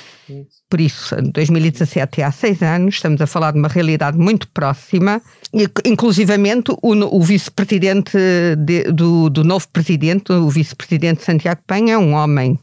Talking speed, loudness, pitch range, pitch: 150 wpm, -15 LUFS, 155-195 Hz, 170 Hz